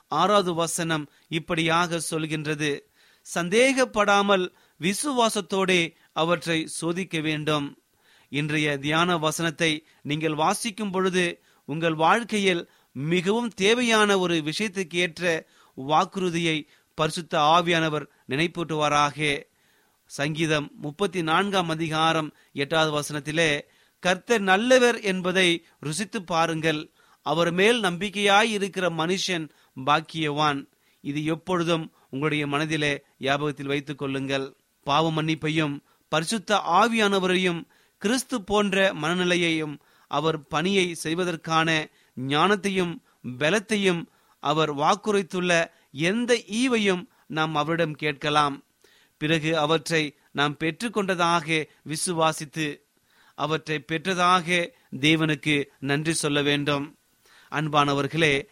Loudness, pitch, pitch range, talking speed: -24 LUFS, 165 Hz, 150-185 Hz, 80 wpm